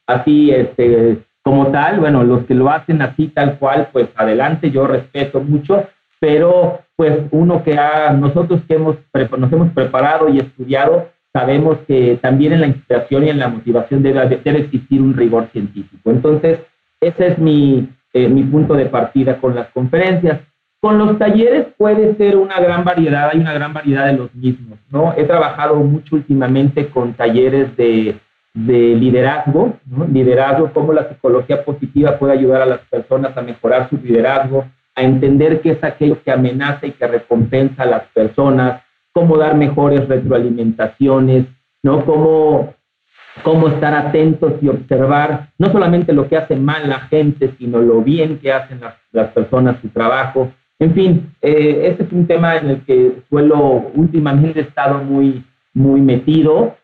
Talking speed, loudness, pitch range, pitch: 165 wpm, -13 LUFS, 130-155 Hz, 140 Hz